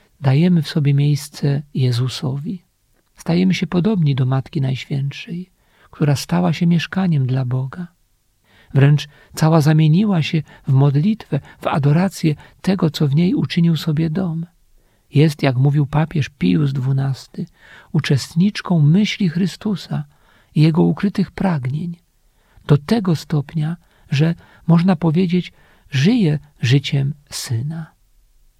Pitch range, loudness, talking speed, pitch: 140-175 Hz, -18 LUFS, 115 wpm, 155 Hz